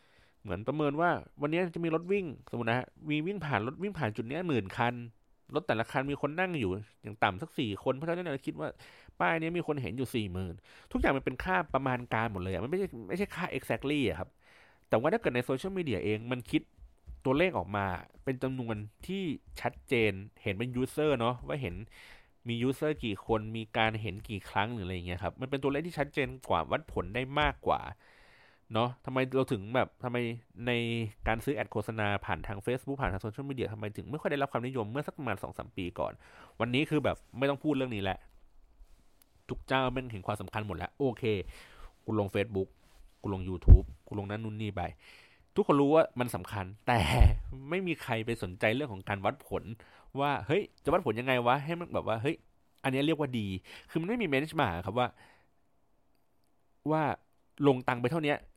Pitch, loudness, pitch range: 120 Hz, -33 LUFS, 105-140 Hz